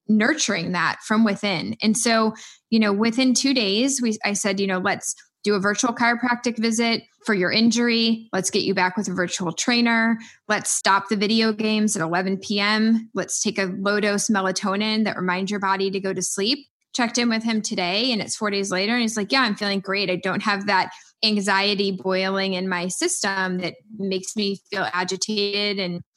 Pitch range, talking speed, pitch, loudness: 190-225 Hz, 195 wpm, 205 Hz, -22 LUFS